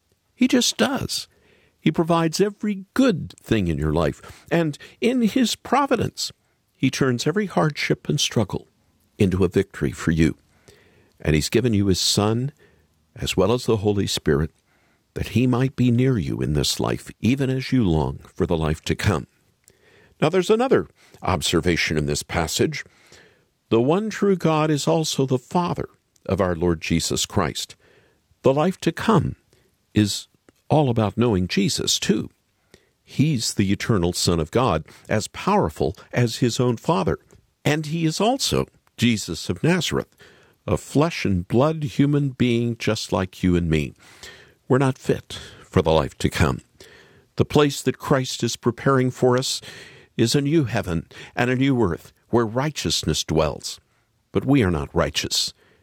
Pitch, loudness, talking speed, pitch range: 120 Hz, -22 LUFS, 160 wpm, 95-145 Hz